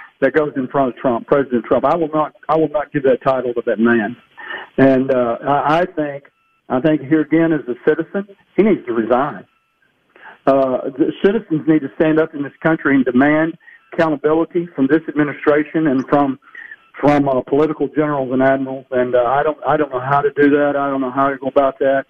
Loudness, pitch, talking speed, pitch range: -17 LUFS, 145 Hz, 210 wpm, 135-155 Hz